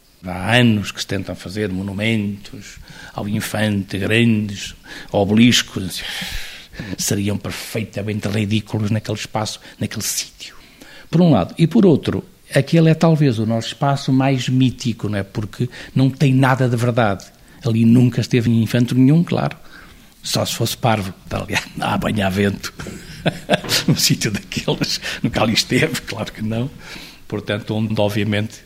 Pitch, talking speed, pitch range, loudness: 110 Hz, 145 wpm, 105-125 Hz, -18 LUFS